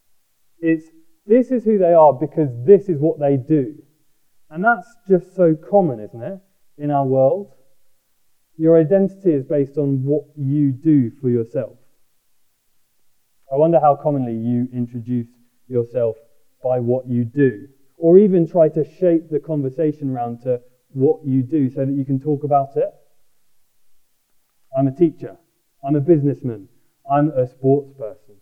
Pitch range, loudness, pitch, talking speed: 130-165 Hz, -18 LUFS, 145 Hz, 150 wpm